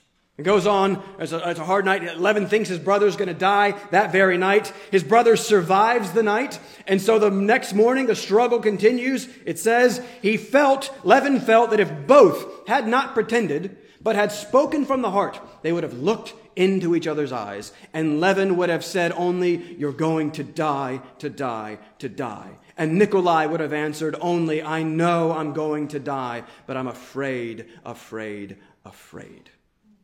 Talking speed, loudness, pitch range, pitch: 180 wpm, -21 LUFS, 155-215 Hz, 185 Hz